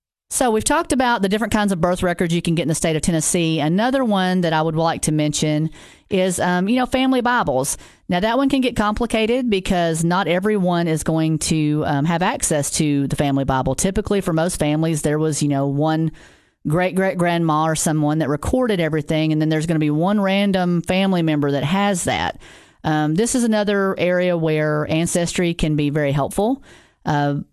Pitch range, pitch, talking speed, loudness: 155-200 Hz, 170 Hz, 200 wpm, -19 LUFS